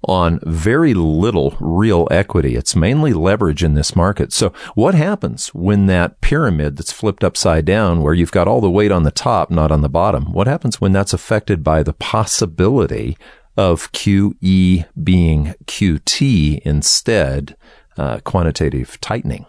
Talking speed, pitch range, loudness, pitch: 155 wpm, 80-100 Hz, -15 LUFS, 85 Hz